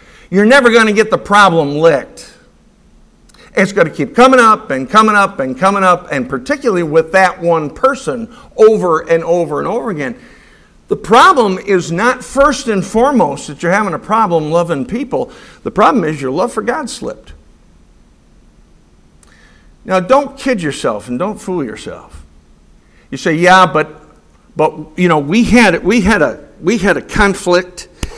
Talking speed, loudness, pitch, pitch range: 165 wpm, -12 LUFS, 185 Hz, 155-230 Hz